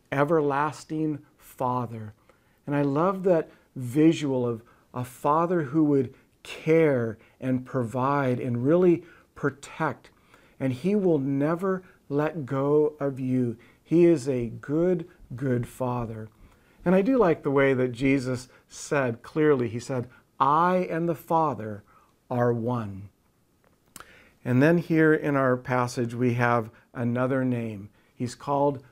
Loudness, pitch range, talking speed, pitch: -25 LUFS, 120-155 Hz, 130 wpm, 135 Hz